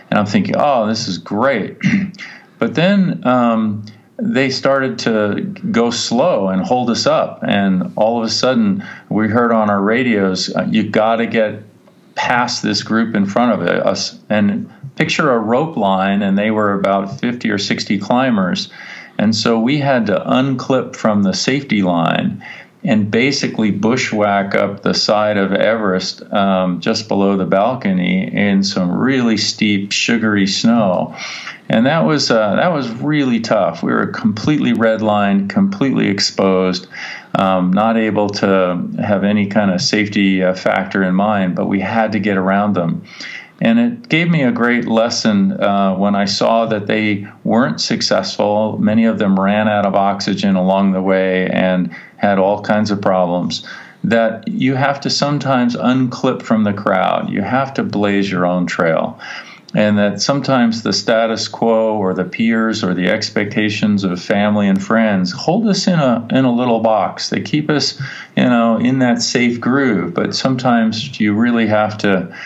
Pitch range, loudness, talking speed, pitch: 100-130 Hz, -15 LUFS, 165 wpm, 110 Hz